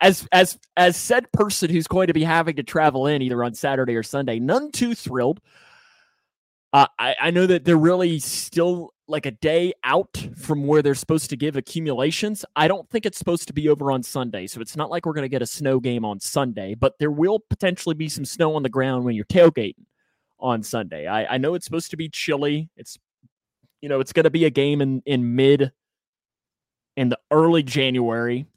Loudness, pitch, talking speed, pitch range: -21 LUFS, 150 Hz, 215 wpm, 135-170 Hz